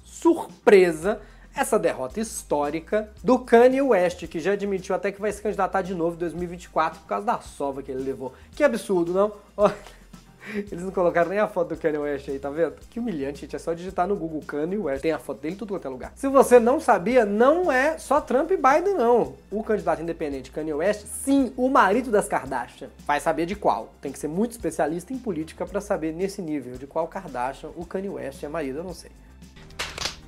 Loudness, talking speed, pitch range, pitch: -24 LUFS, 210 wpm, 155-220 Hz, 185 Hz